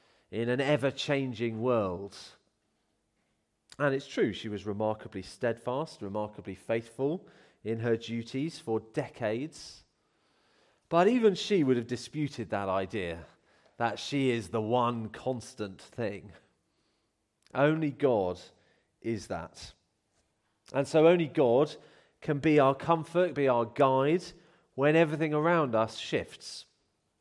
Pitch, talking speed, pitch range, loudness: 125 Hz, 120 wpm, 110-150 Hz, -30 LUFS